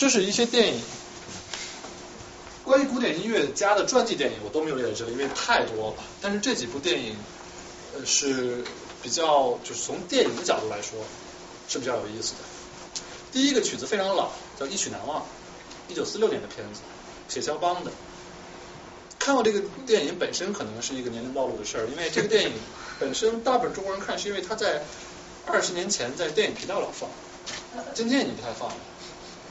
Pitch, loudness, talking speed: 220 Hz, -27 LUFS, 290 characters per minute